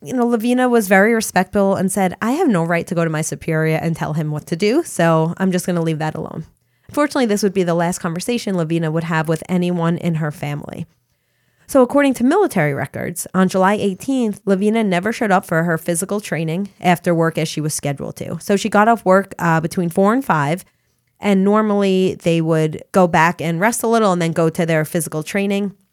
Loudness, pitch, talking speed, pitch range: -17 LUFS, 180 Hz, 220 wpm, 165-200 Hz